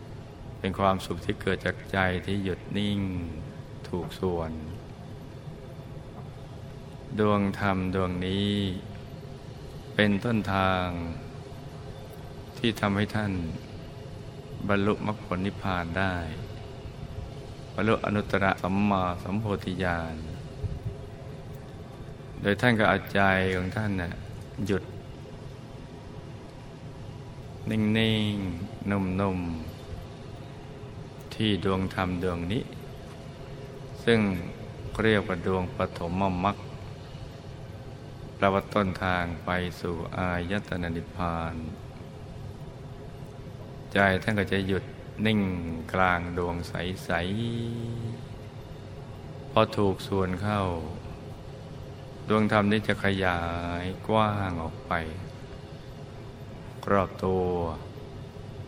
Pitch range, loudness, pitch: 95-135 Hz, -28 LUFS, 105 Hz